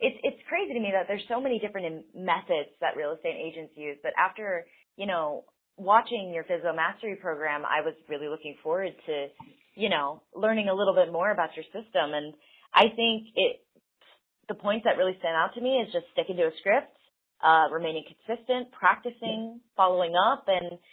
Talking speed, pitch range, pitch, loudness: 190 wpm, 160-230 Hz, 190 Hz, -28 LUFS